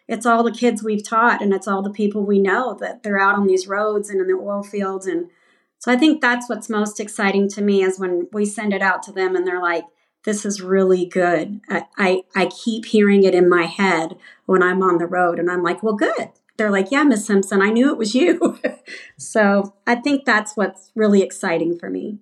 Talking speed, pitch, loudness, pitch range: 235 wpm, 200 Hz, -19 LUFS, 185-220 Hz